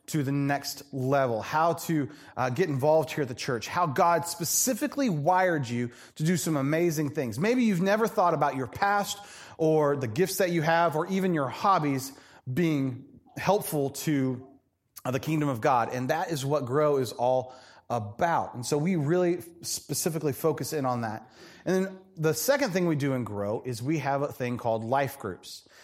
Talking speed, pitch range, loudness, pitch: 190 wpm, 130-170 Hz, -27 LUFS, 150 Hz